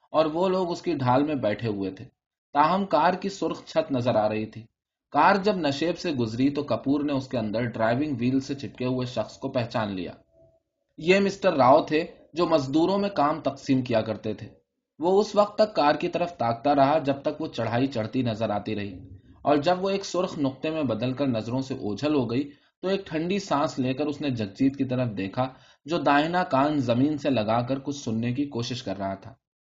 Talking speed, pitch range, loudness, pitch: 215 wpm, 115-160 Hz, -26 LUFS, 135 Hz